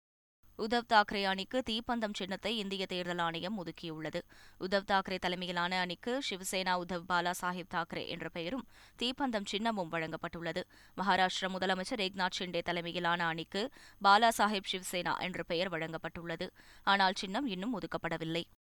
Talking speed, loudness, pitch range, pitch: 125 wpm, -34 LUFS, 170-200 Hz, 185 Hz